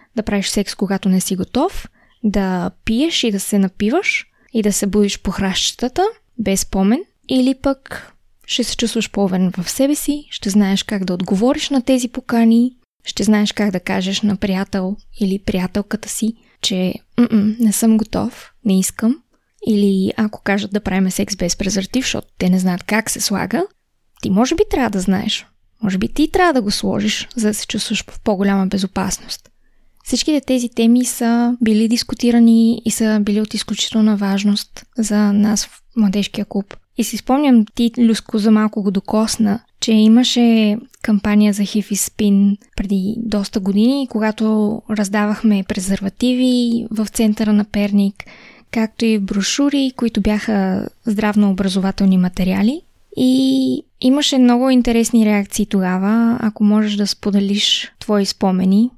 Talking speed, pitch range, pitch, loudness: 155 wpm, 200-235 Hz, 215 Hz, -17 LUFS